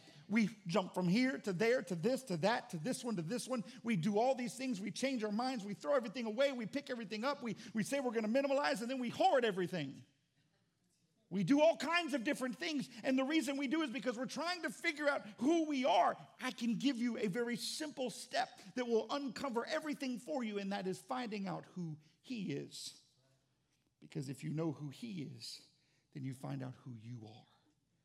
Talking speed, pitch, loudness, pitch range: 220 wpm, 230 Hz, -38 LUFS, 165-265 Hz